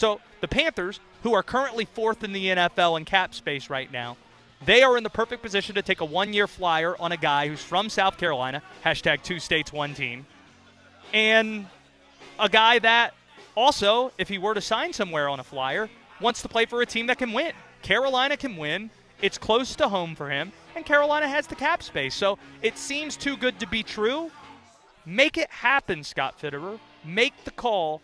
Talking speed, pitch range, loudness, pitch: 200 wpm, 165-245 Hz, -24 LUFS, 210 Hz